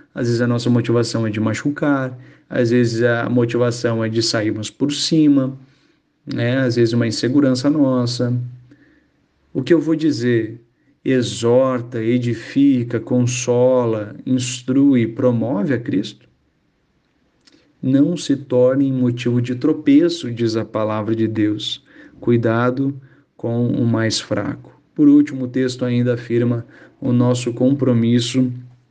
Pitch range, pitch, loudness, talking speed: 120-135 Hz, 125 Hz, -18 LUFS, 125 wpm